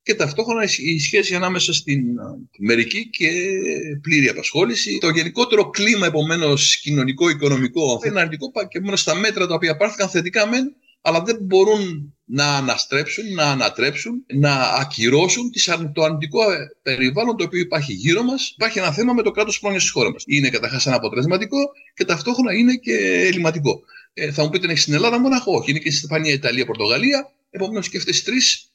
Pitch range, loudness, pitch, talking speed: 145-215 Hz, -18 LUFS, 175 Hz, 180 wpm